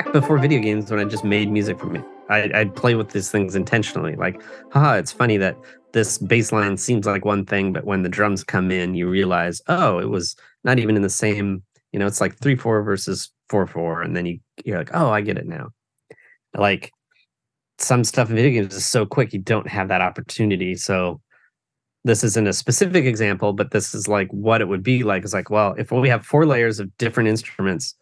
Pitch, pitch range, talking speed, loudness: 105 Hz, 95-115 Hz, 225 wpm, -20 LUFS